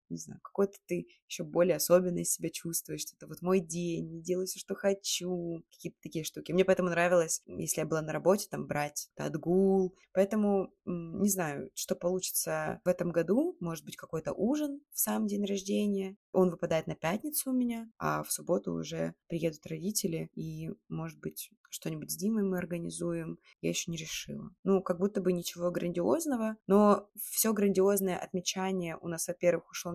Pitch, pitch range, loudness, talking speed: 180 Hz, 165-200 Hz, -32 LUFS, 170 wpm